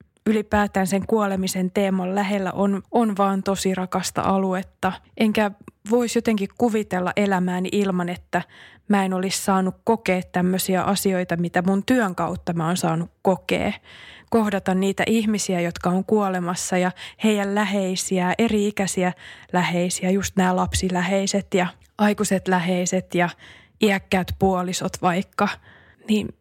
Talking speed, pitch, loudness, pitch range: 125 wpm, 190 Hz, -22 LUFS, 180-205 Hz